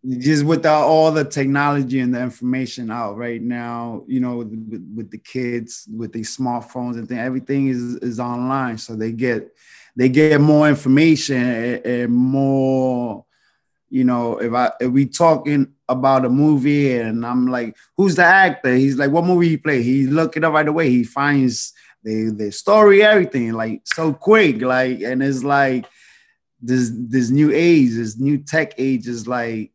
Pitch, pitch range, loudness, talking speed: 130 Hz, 120-145 Hz, -17 LUFS, 175 wpm